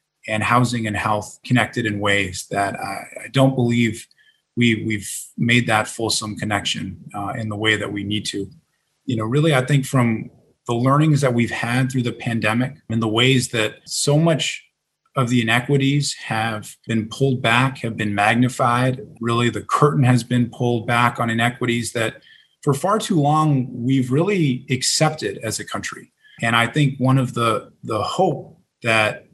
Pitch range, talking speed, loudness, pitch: 115-135 Hz, 175 wpm, -20 LUFS, 120 Hz